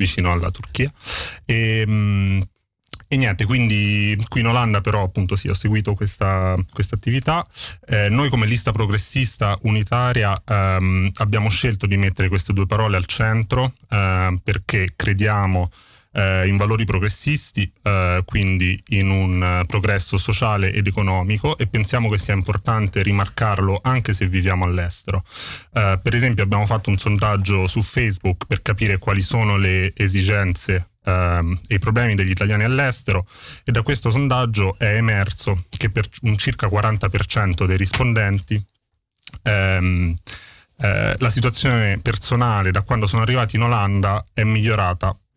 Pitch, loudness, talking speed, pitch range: 105 Hz, -19 LUFS, 145 wpm, 95-115 Hz